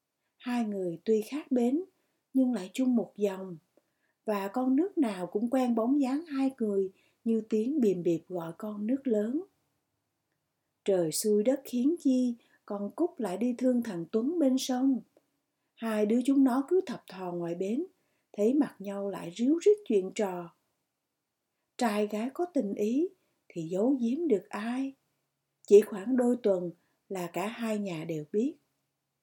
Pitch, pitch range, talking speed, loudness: 230 Hz, 200-265 Hz, 160 wpm, -30 LUFS